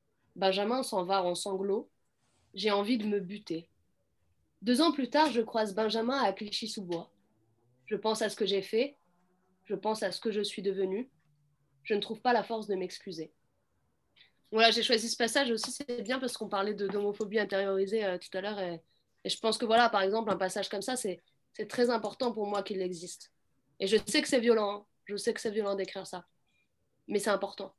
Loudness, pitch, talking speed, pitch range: -31 LUFS, 205 Hz, 205 wpm, 190-225 Hz